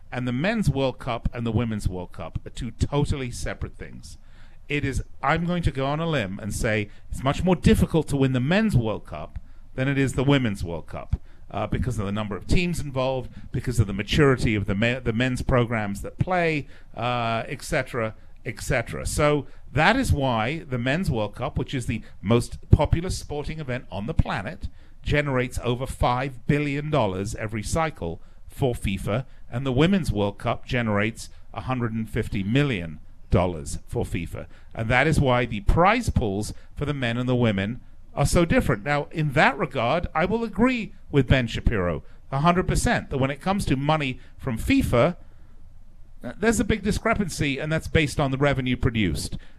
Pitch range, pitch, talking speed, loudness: 105-145 Hz, 125 Hz, 185 wpm, -25 LUFS